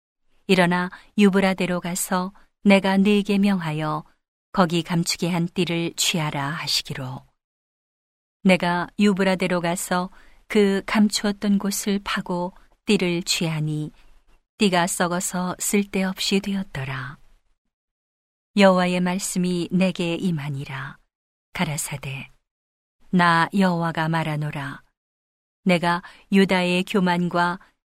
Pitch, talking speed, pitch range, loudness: 180 Hz, 220 characters per minute, 160-195 Hz, -22 LUFS